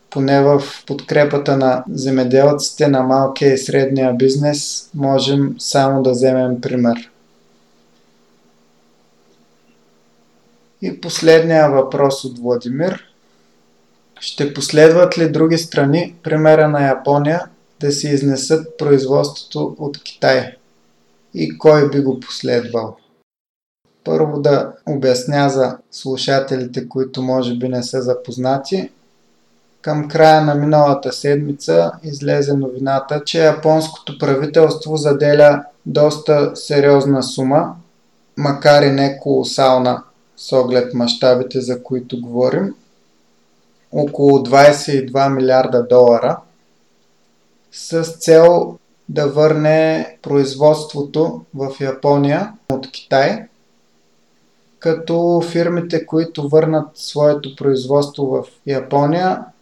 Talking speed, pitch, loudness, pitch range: 95 wpm, 135 Hz, -15 LUFS, 120-150 Hz